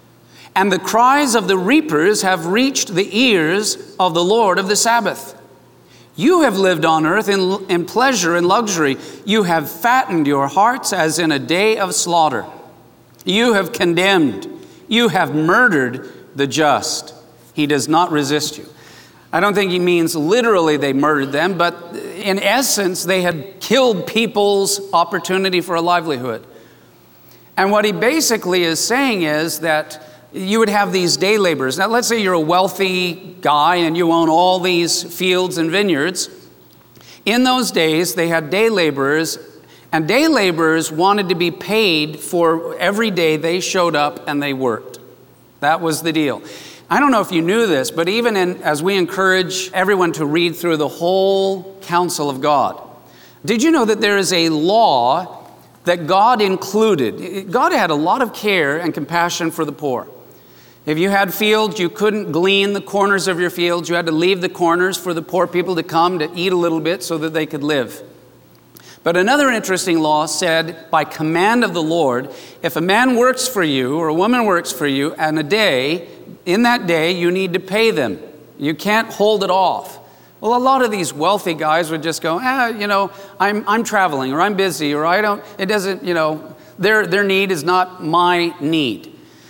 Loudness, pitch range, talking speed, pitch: -16 LUFS, 160-200 Hz, 185 wpm, 180 Hz